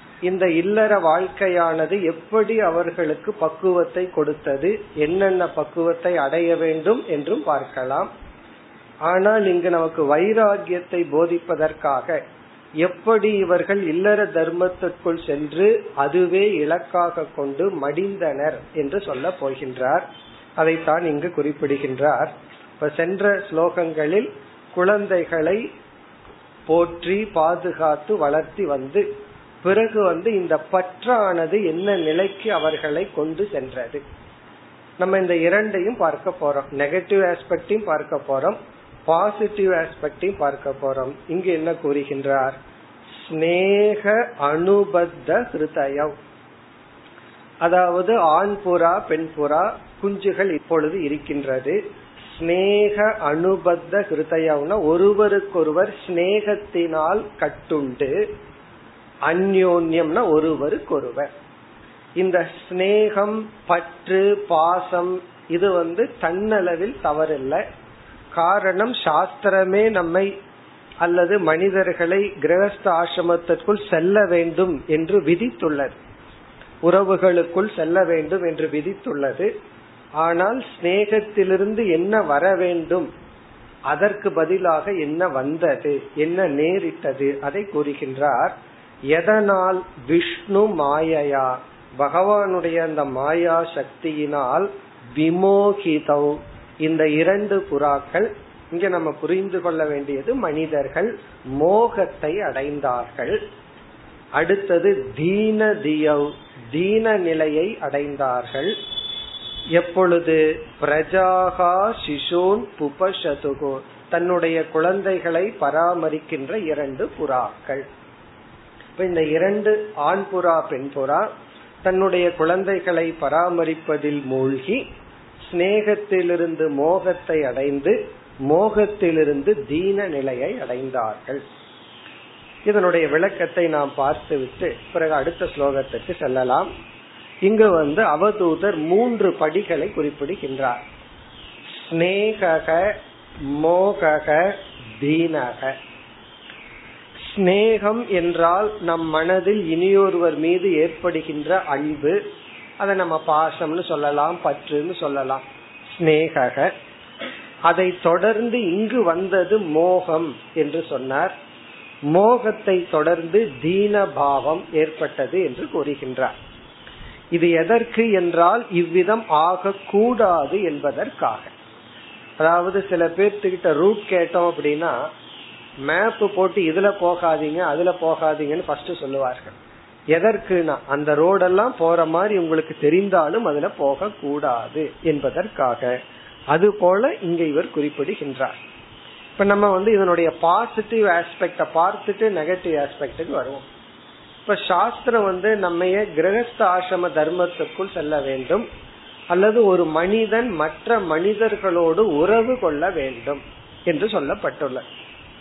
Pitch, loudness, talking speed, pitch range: 170 Hz, -20 LUFS, 75 wpm, 155-195 Hz